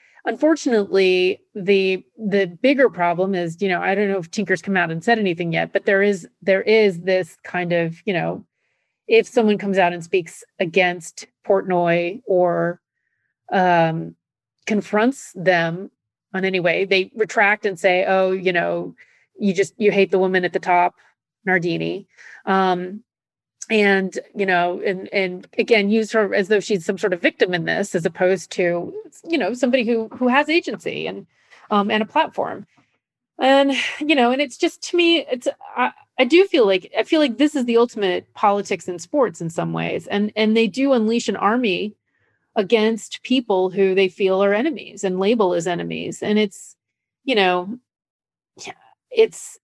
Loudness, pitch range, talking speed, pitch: -19 LUFS, 185-235 Hz, 175 wpm, 200 Hz